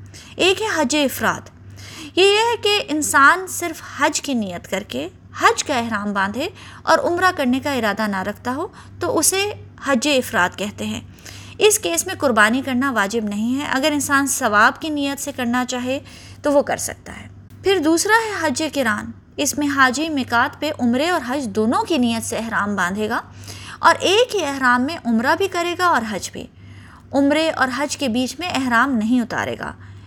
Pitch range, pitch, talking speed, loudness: 230-315 Hz, 275 Hz, 190 wpm, -19 LUFS